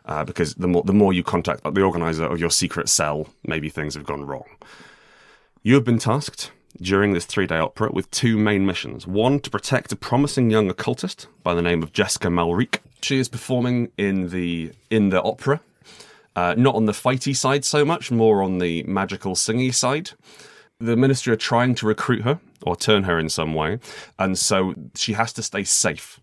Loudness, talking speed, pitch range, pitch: -21 LUFS, 195 wpm, 85-125 Hz, 105 Hz